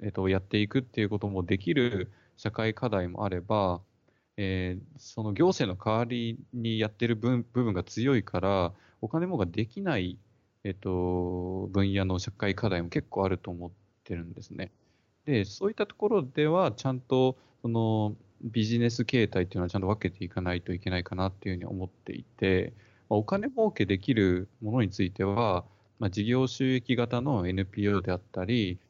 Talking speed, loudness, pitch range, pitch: 355 characters per minute, -30 LUFS, 95-120 Hz, 105 Hz